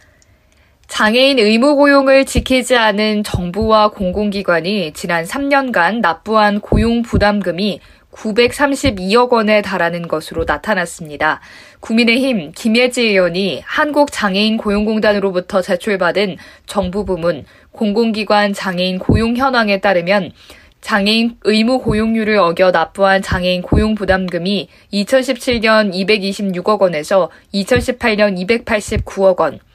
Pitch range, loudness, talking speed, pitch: 185-230 Hz, -14 LUFS, 255 characters per minute, 210 Hz